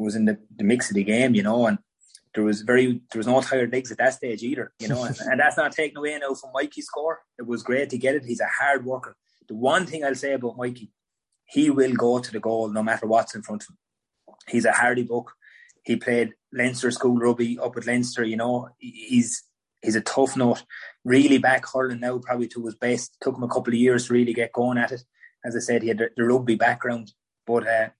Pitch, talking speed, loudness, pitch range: 120 Hz, 245 wpm, -23 LUFS, 115-130 Hz